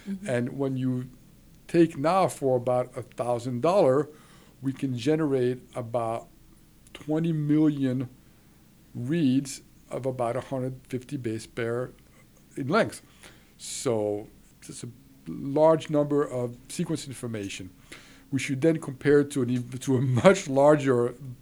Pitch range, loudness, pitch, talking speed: 125-150 Hz, -27 LUFS, 135 Hz, 115 wpm